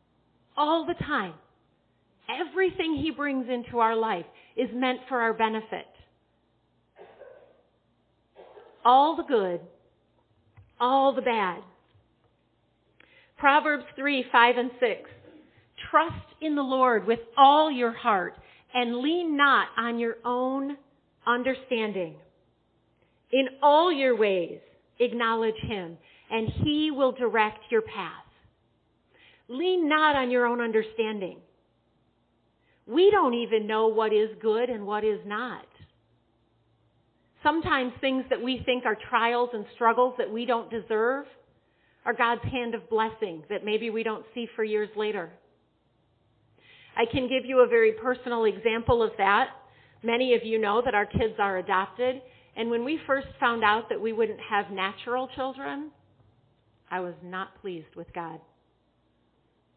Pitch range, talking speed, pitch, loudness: 210-265 Hz, 135 wpm, 235 Hz, -26 LUFS